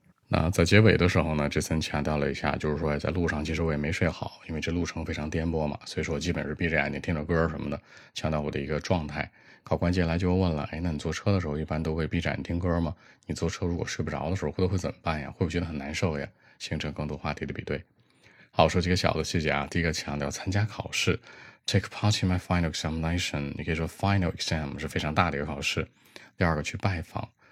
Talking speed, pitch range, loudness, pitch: 435 characters per minute, 75-90 Hz, -28 LUFS, 80 Hz